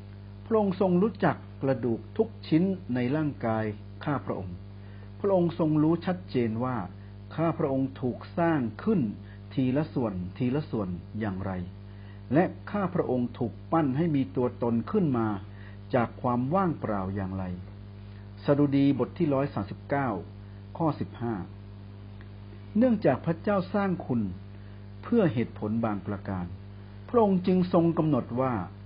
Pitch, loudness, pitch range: 115 Hz, -28 LUFS, 100-155 Hz